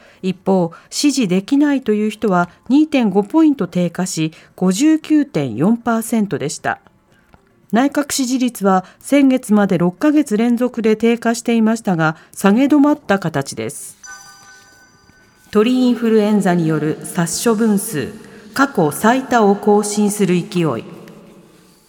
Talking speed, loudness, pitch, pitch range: 225 characters per minute, -16 LUFS, 205 Hz, 175-240 Hz